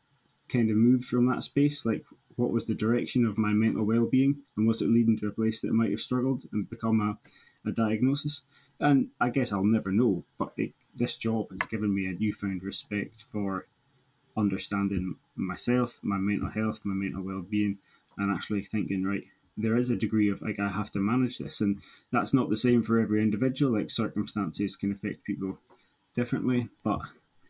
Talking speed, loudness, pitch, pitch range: 190 wpm, -29 LUFS, 110 Hz, 100-120 Hz